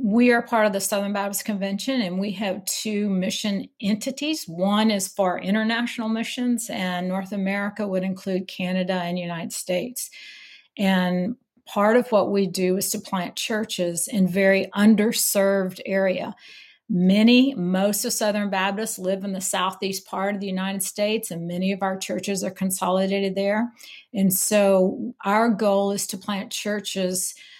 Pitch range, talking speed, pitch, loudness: 190-220 Hz, 155 wpm, 200 Hz, -23 LUFS